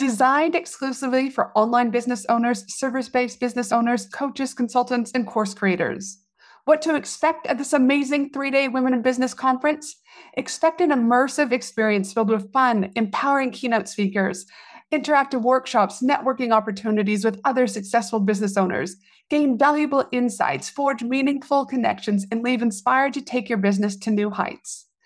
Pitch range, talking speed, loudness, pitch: 220-275 Hz, 150 wpm, -22 LUFS, 250 Hz